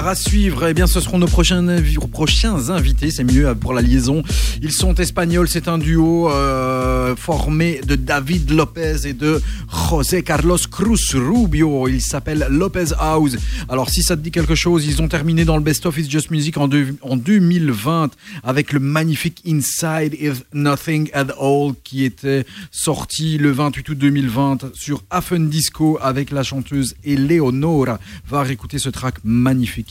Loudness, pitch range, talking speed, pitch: -17 LUFS, 135-165 Hz, 175 wpm, 150 Hz